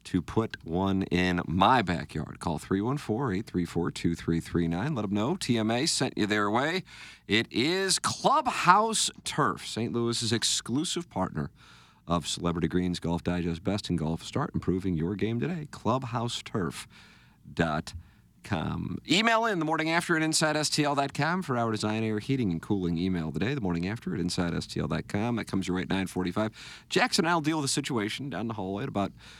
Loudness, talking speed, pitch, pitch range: -28 LUFS, 160 wpm, 105 Hz, 90-140 Hz